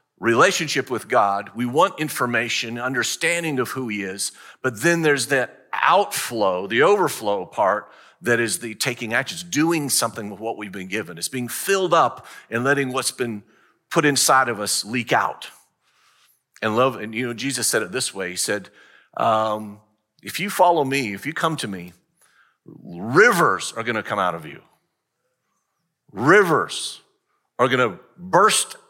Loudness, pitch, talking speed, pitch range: -21 LUFS, 120 Hz, 165 wpm, 110-140 Hz